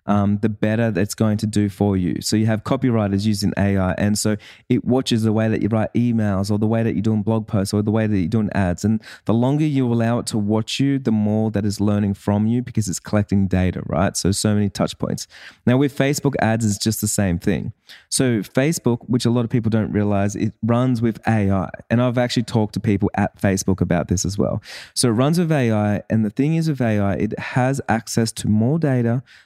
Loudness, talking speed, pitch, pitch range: -20 LUFS, 240 wpm, 110 Hz, 100-120 Hz